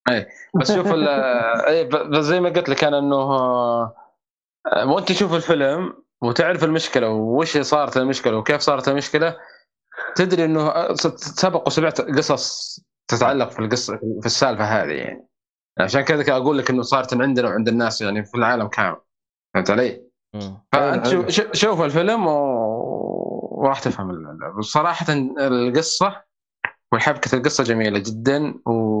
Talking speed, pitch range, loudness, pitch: 130 wpm, 115-160 Hz, -20 LUFS, 135 Hz